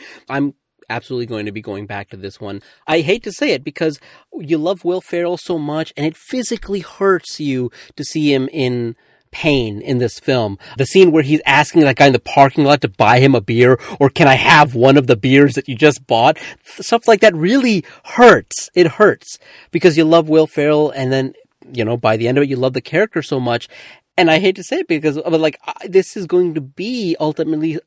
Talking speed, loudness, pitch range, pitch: 230 wpm, -14 LUFS, 130-170 Hz, 150 Hz